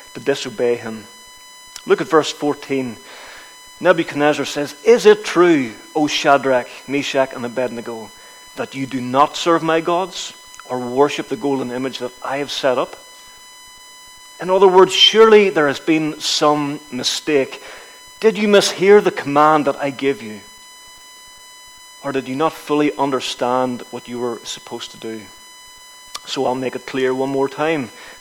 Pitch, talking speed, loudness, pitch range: 150 Hz, 155 wpm, -17 LUFS, 130-210 Hz